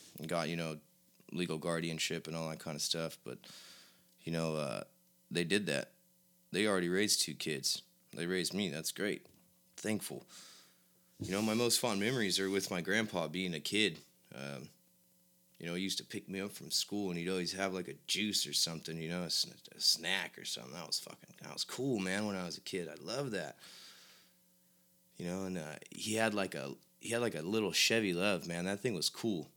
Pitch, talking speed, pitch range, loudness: 85 Hz, 210 wpm, 75-95 Hz, -36 LUFS